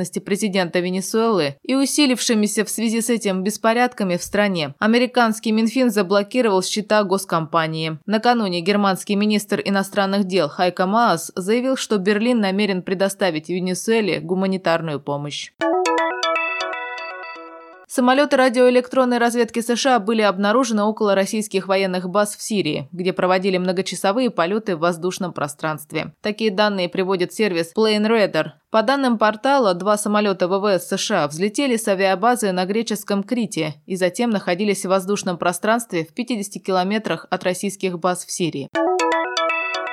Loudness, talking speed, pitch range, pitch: -20 LUFS, 125 wpm, 180-220 Hz, 200 Hz